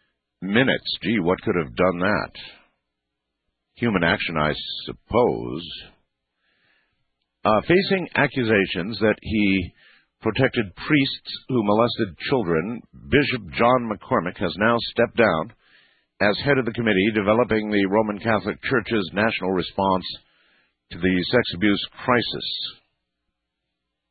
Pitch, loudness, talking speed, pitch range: 105 Hz, -22 LUFS, 110 wpm, 90-120 Hz